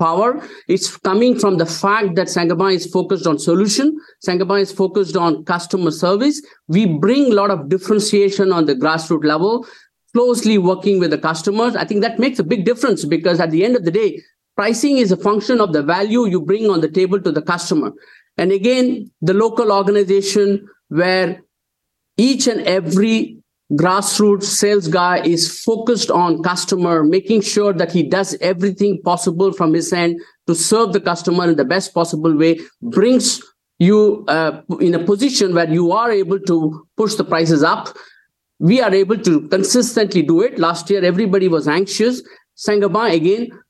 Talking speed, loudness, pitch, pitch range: 175 wpm, -16 LUFS, 195 Hz, 175-210 Hz